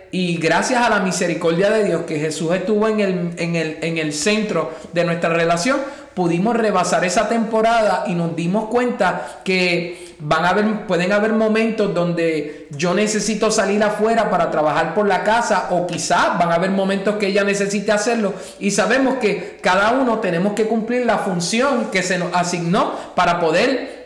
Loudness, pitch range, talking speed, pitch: -18 LUFS, 175-220 Hz, 175 wpm, 195 Hz